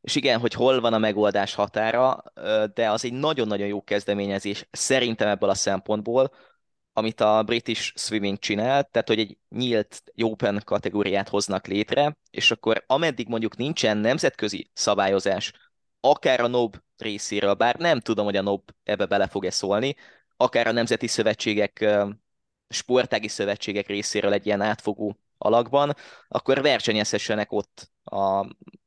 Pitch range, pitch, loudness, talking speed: 100-120 Hz, 105 Hz, -24 LUFS, 140 wpm